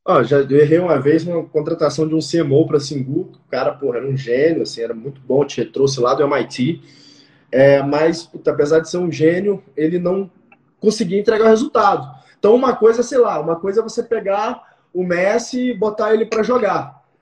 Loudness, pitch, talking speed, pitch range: -17 LUFS, 165 Hz, 205 wpm, 145-215 Hz